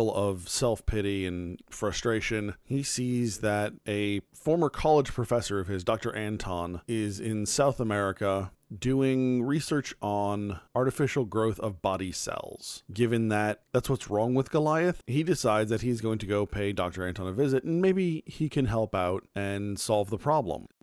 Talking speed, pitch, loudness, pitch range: 165 wpm, 110 Hz, -29 LUFS, 100-130 Hz